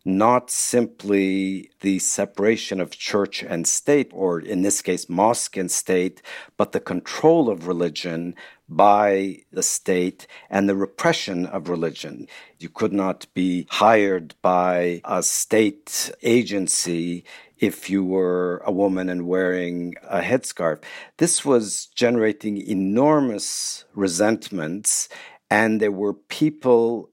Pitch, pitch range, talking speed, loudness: 95 Hz, 90-110 Hz, 120 wpm, -21 LUFS